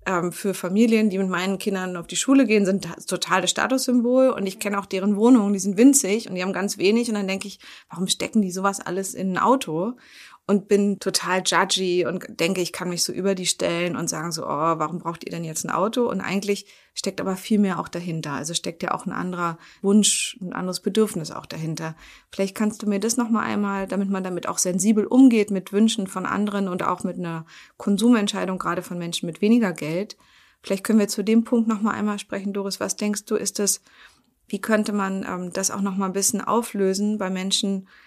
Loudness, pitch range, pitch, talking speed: -22 LUFS, 180-210 Hz, 195 Hz, 220 wpm